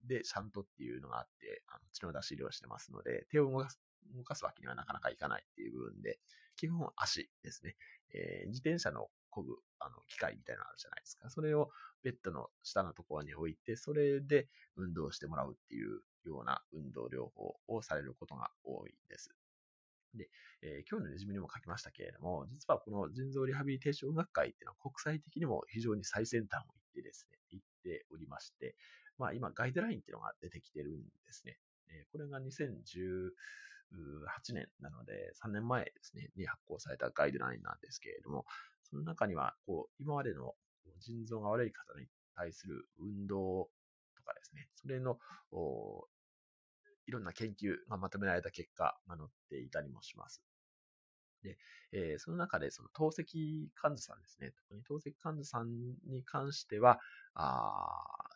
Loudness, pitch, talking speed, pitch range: -41 LUFS, 135 Hz, 360 characters per minute, 105-165 Hz